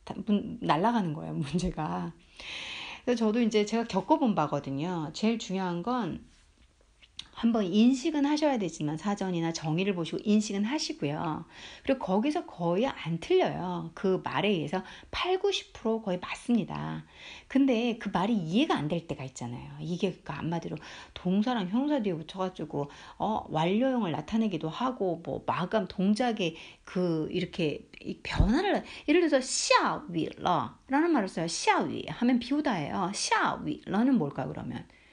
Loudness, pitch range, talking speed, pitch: -30 LUFS, 170-245 Hz, 305 characters per minute, 200 Hz